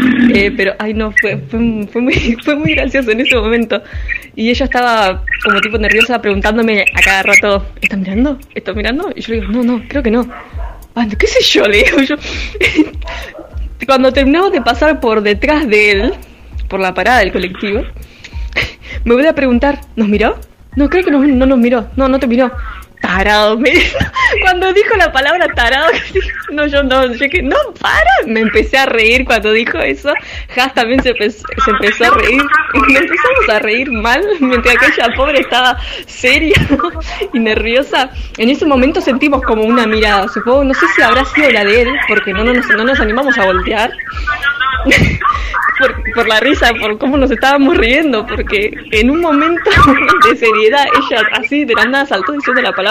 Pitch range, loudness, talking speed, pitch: 225-285 Hz, -11 LUFS, 185 wpm, 255 Hz